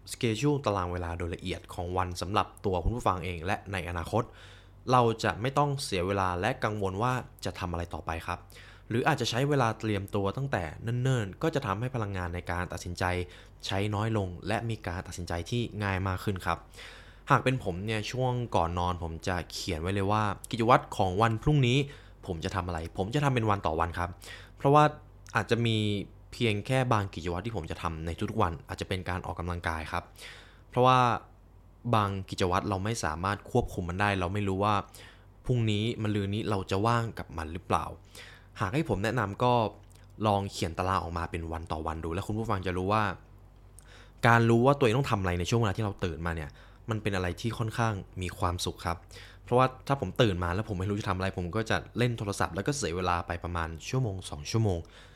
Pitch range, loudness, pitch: 90-115 Hz, -30 LUFS, 100 Hz